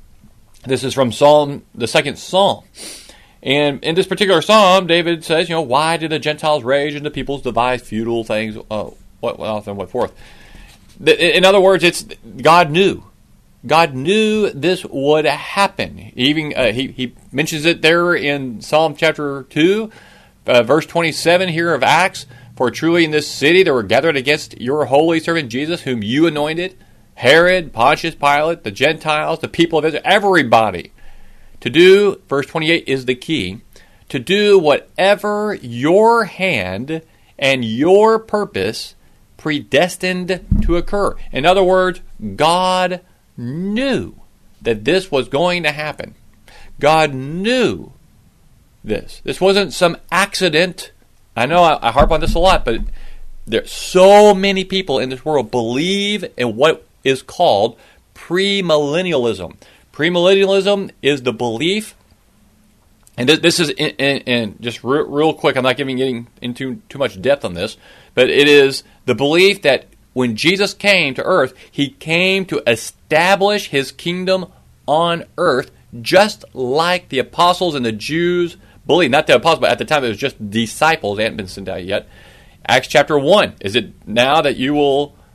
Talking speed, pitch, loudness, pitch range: 160 wpm, 155 Hz, -15 LUFS, 130-185 Hz